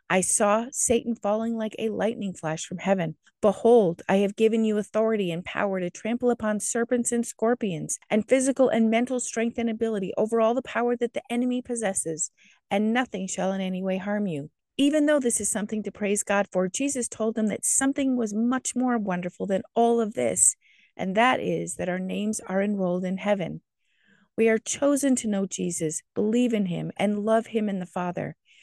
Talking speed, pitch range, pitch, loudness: 195 wpm, 195-235 Hz, 215 Hz, -25 LUFS